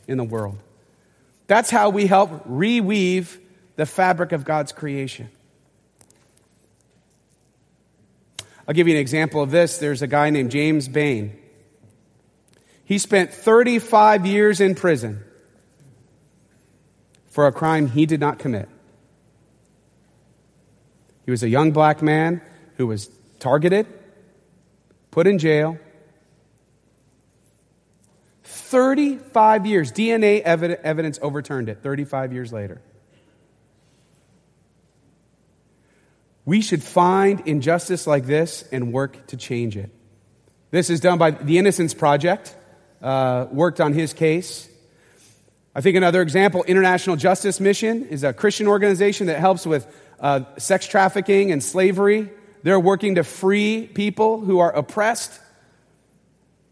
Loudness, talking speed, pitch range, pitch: -19 LUFS, 115 wpm, 140-195 Hz, 165 Hz